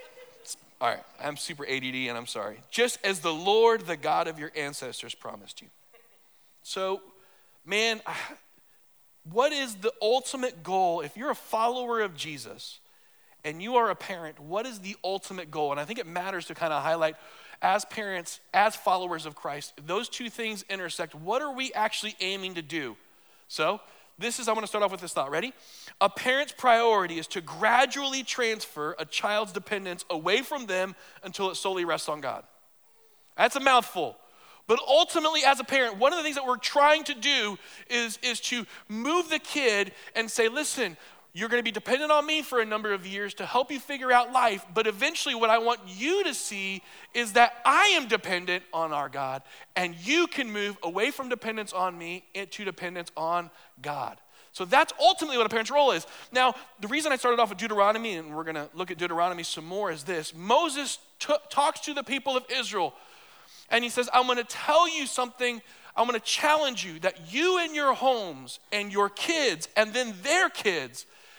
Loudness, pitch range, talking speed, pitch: -27 LUFS, 185-265 Hz, 195 wpm, 225 Hz